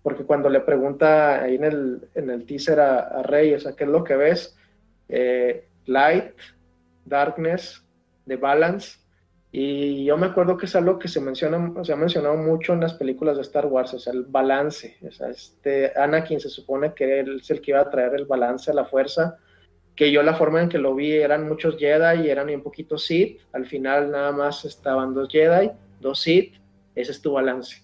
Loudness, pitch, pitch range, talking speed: -21 LUFS, 145 Hz, 130-155 Hz, 205 wpm